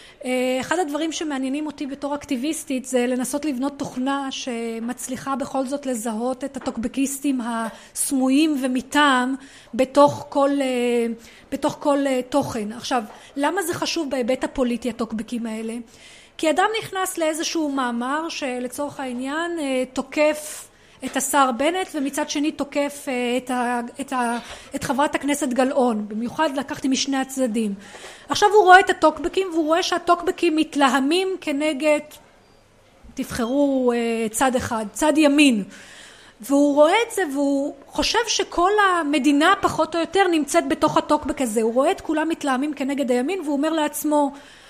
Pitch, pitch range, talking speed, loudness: 280 Hz, 255-310 Hz, 130 wpm, -21 LUFS